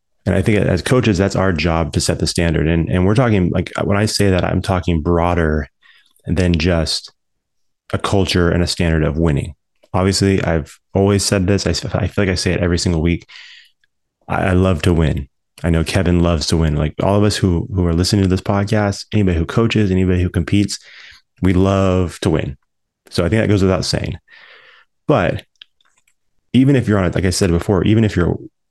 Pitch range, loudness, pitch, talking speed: 85-100 Hz, -16 LUFS, 90 Hz, 210 wpm